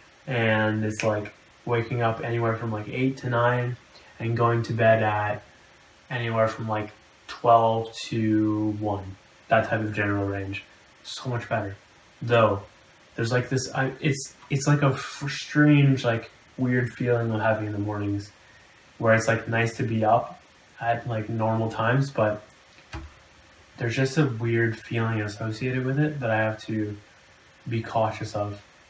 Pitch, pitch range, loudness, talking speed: 115 Hz, 105-120 Hz, -25 LUFS, 155 wpm